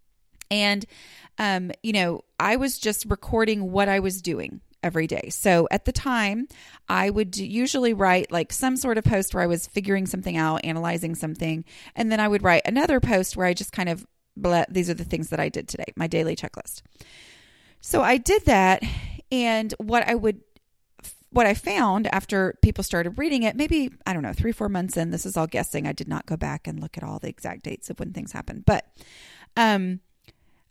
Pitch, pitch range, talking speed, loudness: 195 Hz, 175-225 Hz, 205 wpm, -24 LUFS